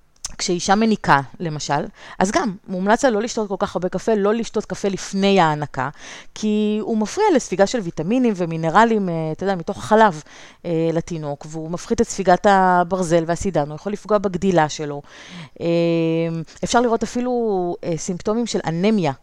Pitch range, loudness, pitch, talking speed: 165-215 Hz, -20 LUFS, 190 Hz, 145 wpm